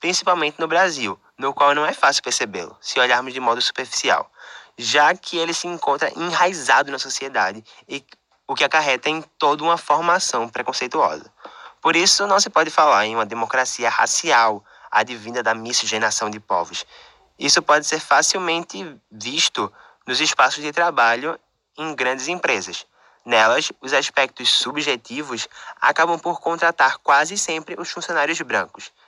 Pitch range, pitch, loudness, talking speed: 125-170 Hz, 150 Hz, -19 LUFS, 145 wpm